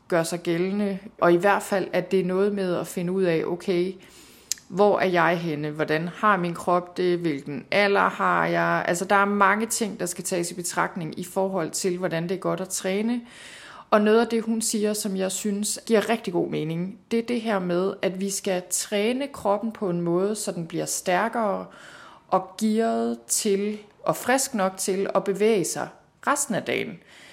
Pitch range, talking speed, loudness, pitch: 175-210 Hz, 200 wpm, -24 LUFS, 190 Hz